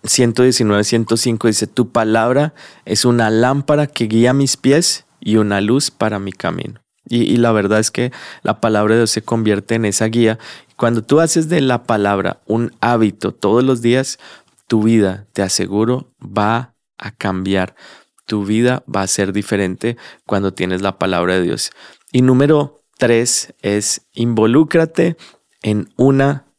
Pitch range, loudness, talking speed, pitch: 105-125 Hz, -16 LUFS, 160 wpm, 115 Hz